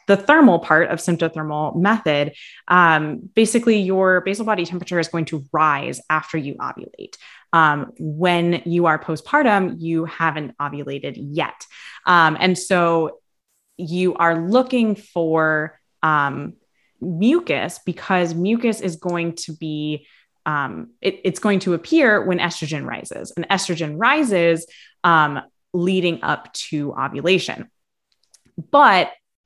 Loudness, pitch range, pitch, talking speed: -19 LUFS, 160-190 Hz, 175 Hz, 125 wpm